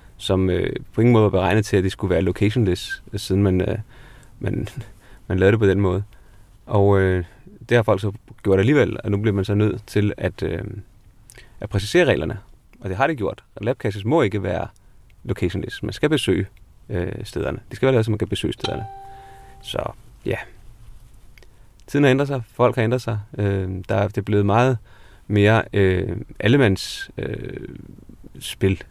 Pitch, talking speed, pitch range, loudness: 105 Hz, 160 wpm, 95-115 Hz, -21 LUFS